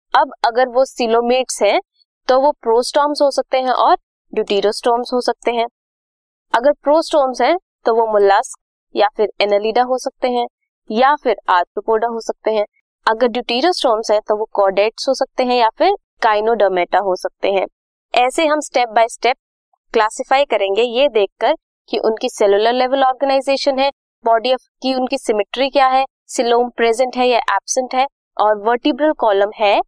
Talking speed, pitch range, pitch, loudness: 165 wpm, 220-270 Hz, 245 Hz, -16 LUFS